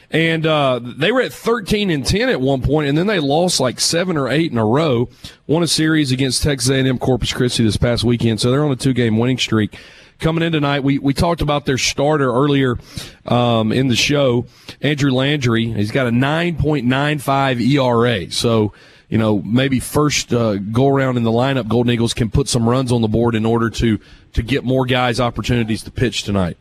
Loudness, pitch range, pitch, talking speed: -17 LUFS, 115-145 Hz, 130 Hz, 215 wpm